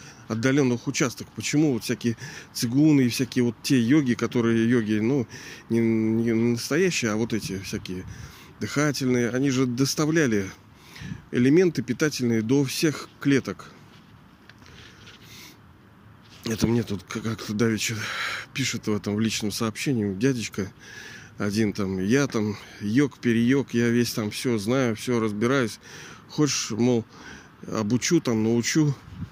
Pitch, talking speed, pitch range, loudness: 120 Hz, 125 wpm, 110-130 Hz, -24 LUFS